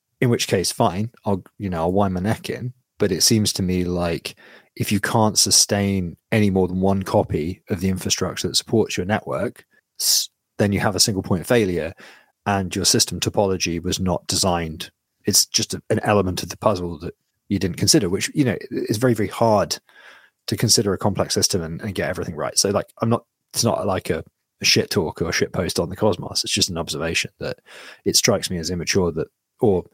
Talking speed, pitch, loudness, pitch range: 210 wpm, 100 Hz, -20 LUFS, 90-105 Hz